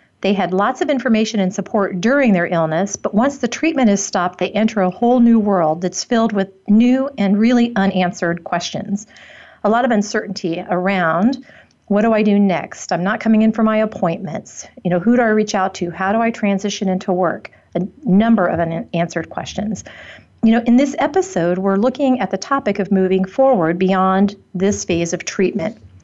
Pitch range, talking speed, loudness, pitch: 185-225 Hz, 195 wpm, -17 LUFS, 200 Hz